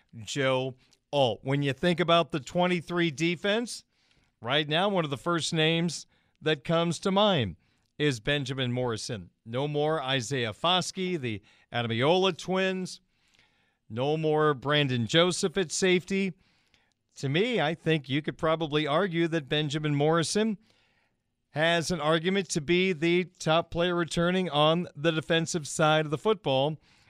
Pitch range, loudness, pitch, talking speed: 140-175 Hz, -27 LUFS, 160 Hz, 140 wpm